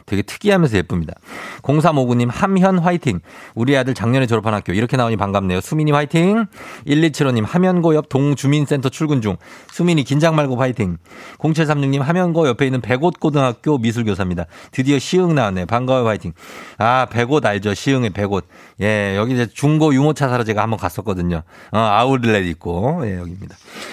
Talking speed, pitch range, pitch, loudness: 370 characters per minute, 105-150 Hz, 130 Hz, -17 LUFS